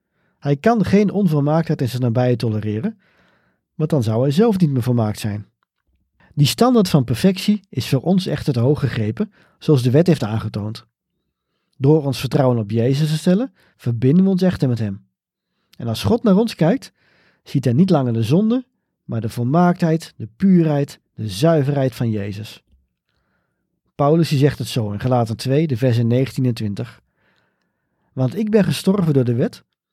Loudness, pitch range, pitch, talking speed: -18 LUFS, 120-175 Hz, 140 Hz, 170 wpm